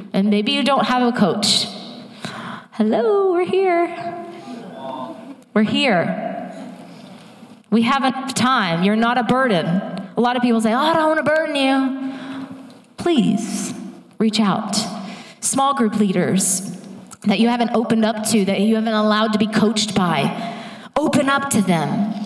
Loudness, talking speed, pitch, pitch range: -18 LUFS, 150 wpm, 225 Hz, 215-260 Hz